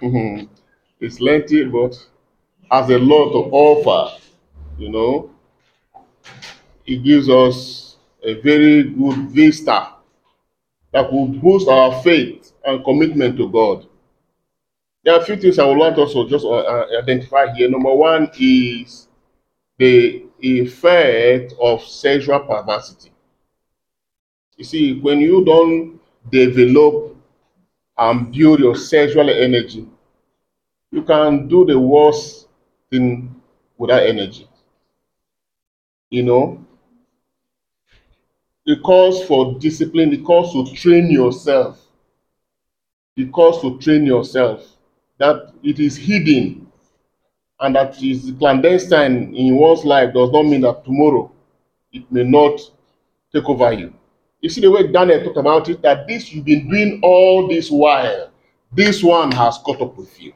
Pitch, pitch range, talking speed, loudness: 145 Hz, 125-165 Hz, 125 wpm, -14 LUFS